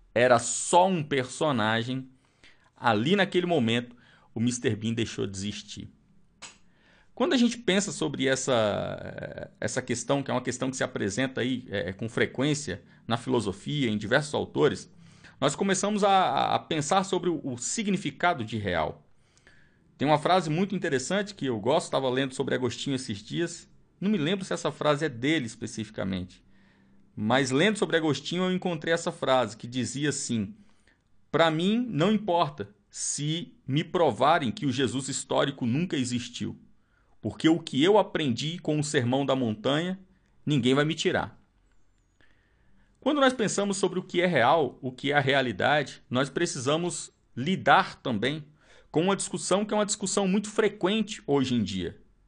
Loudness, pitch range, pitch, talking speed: -27 LUFS, 120-180 Hz, 140 Hz, 155 wpm